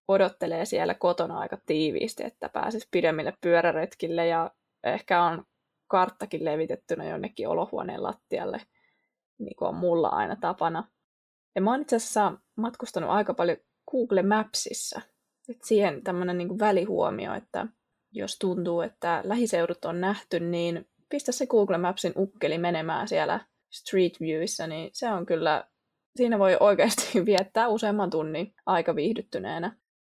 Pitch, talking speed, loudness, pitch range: 185 Hz, 135 wpm, -27 LUFS, 170-215 Hz